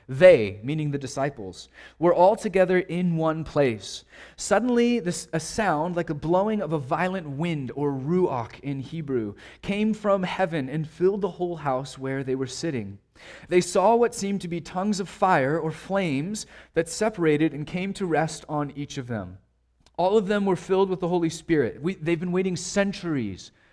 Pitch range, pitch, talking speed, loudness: 140-185 Hz, 165 Hz, 180 wpm, -25 LUFS